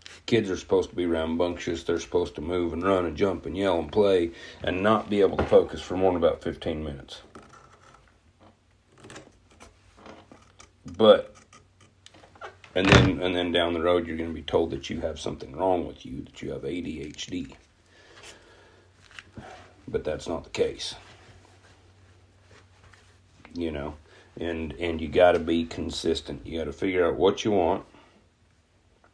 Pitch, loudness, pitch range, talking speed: 90 Hz, -26 LUFS, 85-95 Hz, 155 wpm